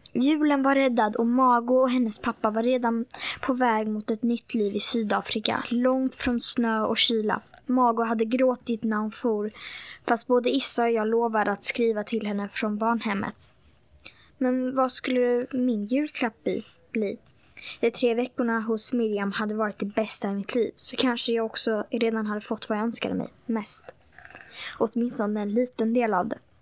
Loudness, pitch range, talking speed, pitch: -25 LUFS, 220-250 Hz, 175 wpm, 235 Hz